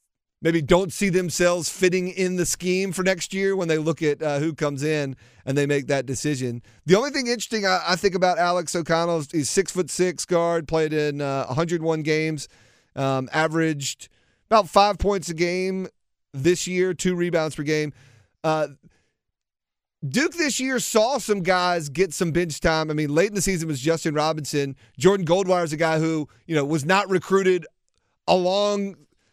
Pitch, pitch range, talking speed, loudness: 170 Hz, 150-185 Hz, 180 wpm, -23 LUFS